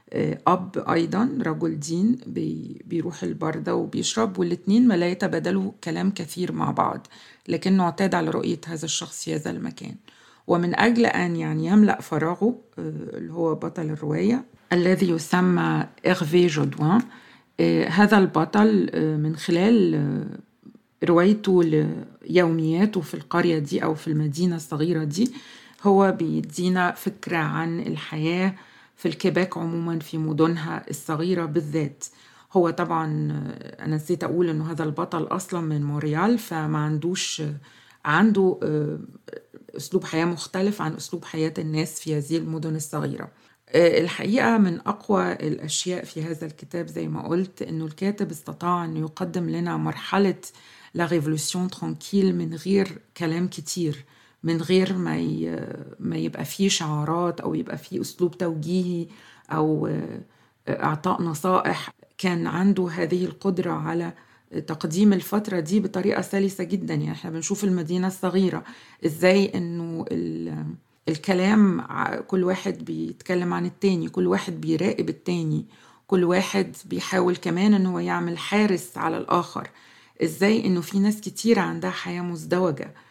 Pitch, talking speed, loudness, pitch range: 175 Hz, 125 wpm, -24 LUFS, 160-190 Hz